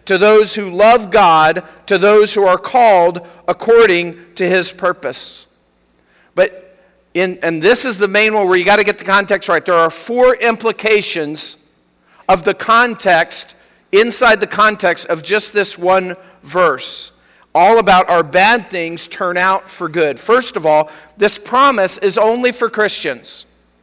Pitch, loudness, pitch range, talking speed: 190 Hz, -13 LUFS, 175-215 Hz, 160 wpm